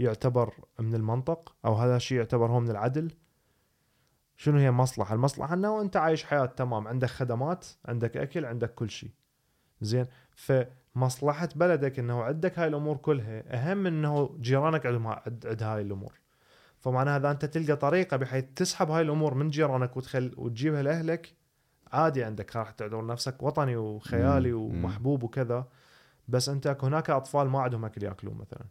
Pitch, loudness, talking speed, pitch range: 130 Hz, -29 LUFS, 155 wpm, 120-150 Hz